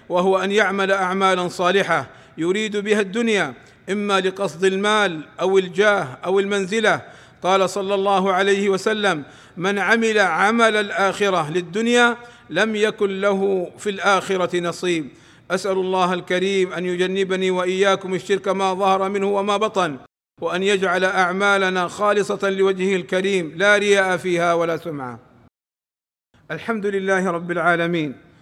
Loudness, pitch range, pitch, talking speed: -19 LUFS, 180-200 Hz, 190 Hz, 120 wpm